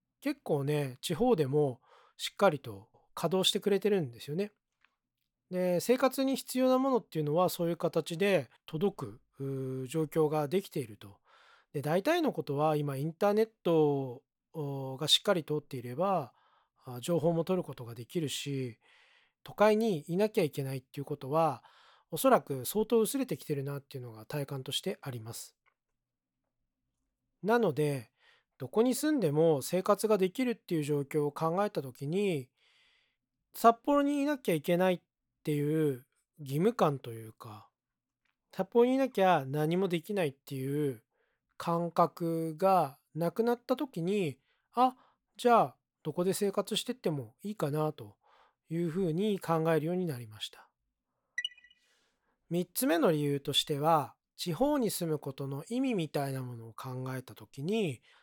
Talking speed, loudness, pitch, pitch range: 295 characters per minute, -31 LUFS, 165 Hz, 140-205 Hz